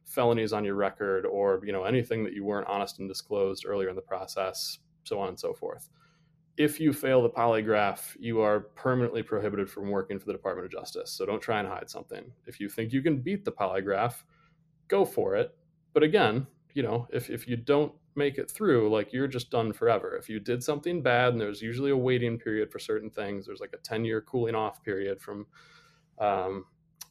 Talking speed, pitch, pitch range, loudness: 210 wpm, 120 Hz, 105-155 Hz, -29 LUFS